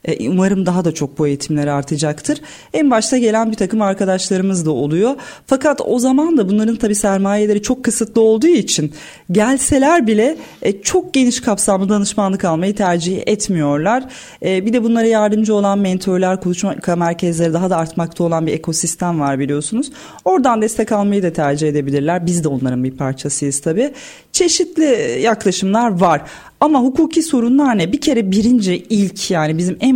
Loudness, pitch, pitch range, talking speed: -15 LUFS, 200 Hz, 170-245 Hz, 155 wpm